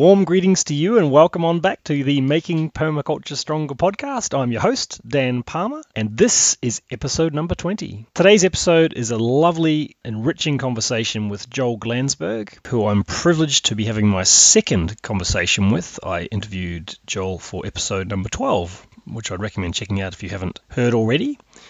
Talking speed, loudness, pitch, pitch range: 170 wpm, -19 LUFS, 125 Hz, 105-160 Hz